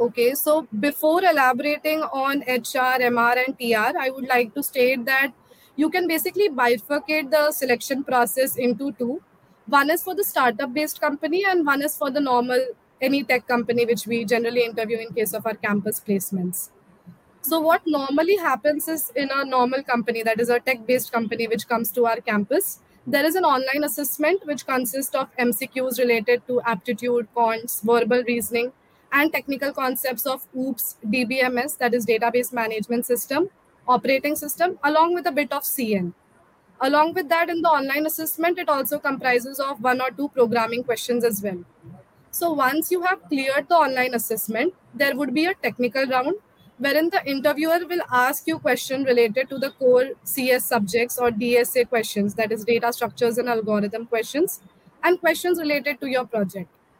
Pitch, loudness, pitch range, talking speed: 260 Hz, -22 LUFS, 235-295 Hz, 170 wpm